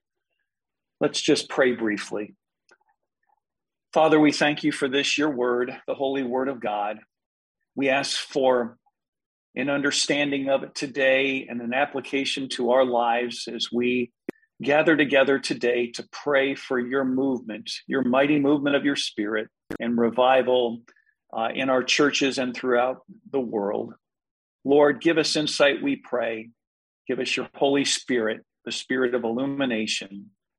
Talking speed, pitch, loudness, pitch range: 140 wpm, 135 Hz, -24 LUFS, 125-145 Hz